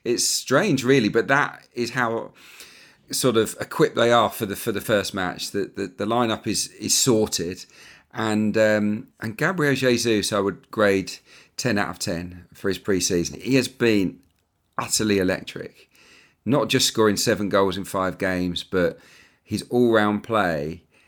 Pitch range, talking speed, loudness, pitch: 95-120 Hz, 170 wpm, -22 LUFS, 105 Hz